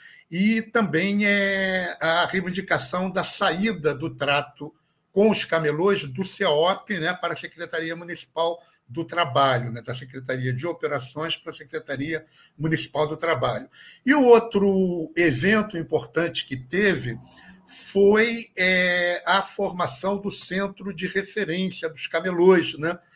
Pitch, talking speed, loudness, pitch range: 175 Hz, 130 wpm, -23 LUFS, 155-195 Hz